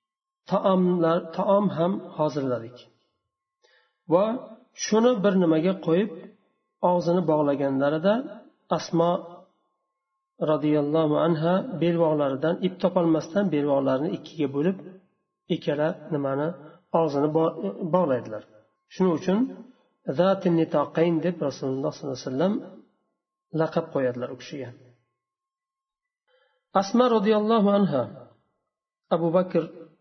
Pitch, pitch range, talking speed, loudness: 175 Hz, 150-200 Hz, 85 wpm, -25 LUFS